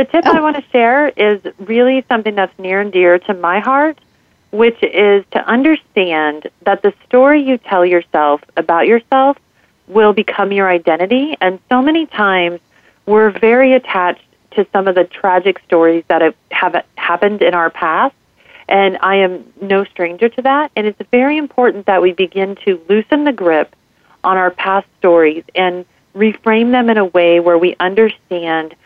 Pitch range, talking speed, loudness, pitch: 180-235 Hz, 170 wpm, -13 LUFS, 200 Hz